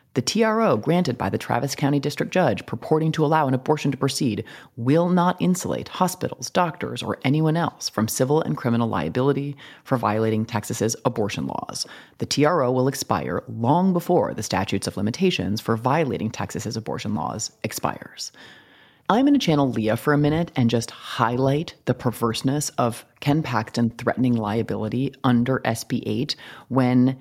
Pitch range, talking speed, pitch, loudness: 115-150 Hz, 160 wpm, 130 Hz, -23 LUFS